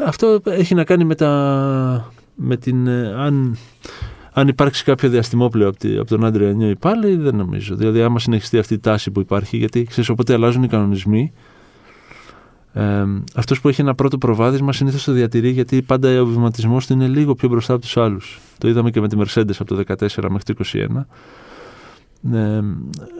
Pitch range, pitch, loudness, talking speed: 110-135 Hz, 120 Hz, -17 LUFS, 190 wpm